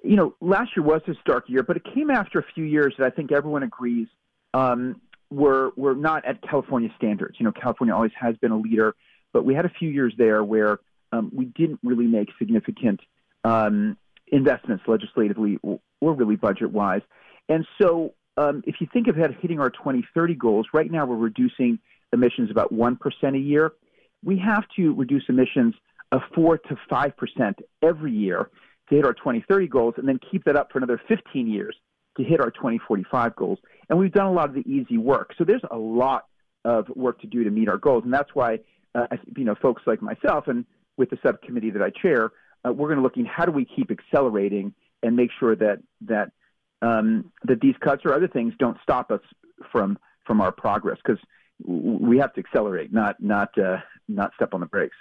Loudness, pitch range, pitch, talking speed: -23 LUFS, 125-200 Hz, 155 Hz, 205 wpm